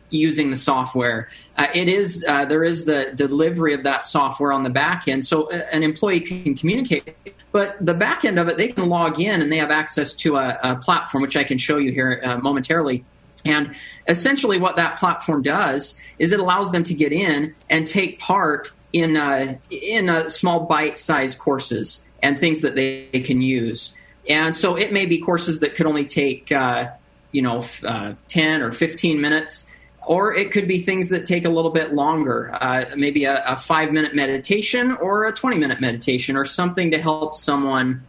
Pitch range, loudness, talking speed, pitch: 135-170 Hz, -20 LUFS, 200 wpm, 155 Hz